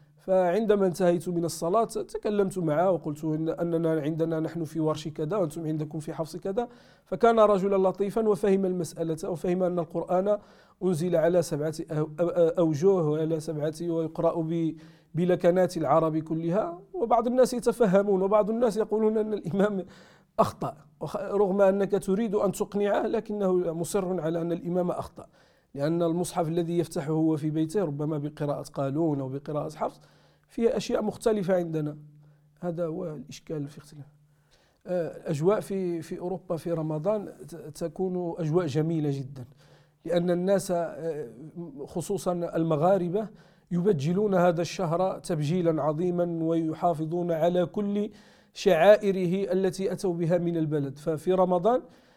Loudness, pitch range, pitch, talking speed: -27 LUFS, 160-190 Hz, 175 Hz, 125 wpm